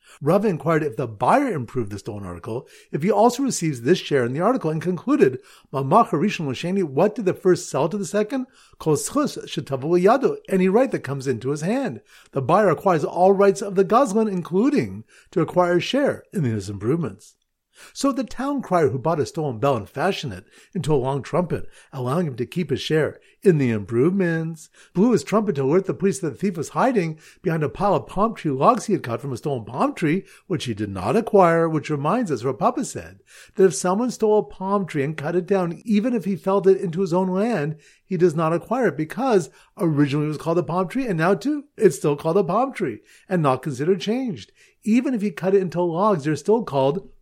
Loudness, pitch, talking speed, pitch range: -22 LUFS, 180 Hz, 215 wpm, 150-210 Hz